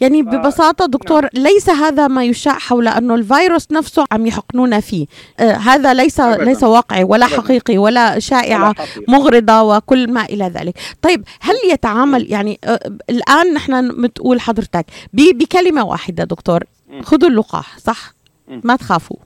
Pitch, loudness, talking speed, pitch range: 250 Hz, -13 LUFS, 135 wpm, 220-290 Hz